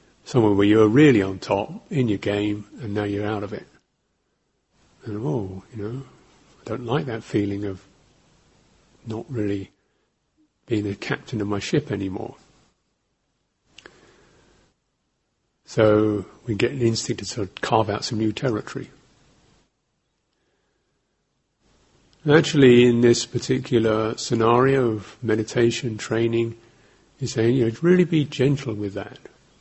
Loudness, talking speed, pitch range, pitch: -22 LUFS, 130 wpm, 105-125 Hz, 115 Hz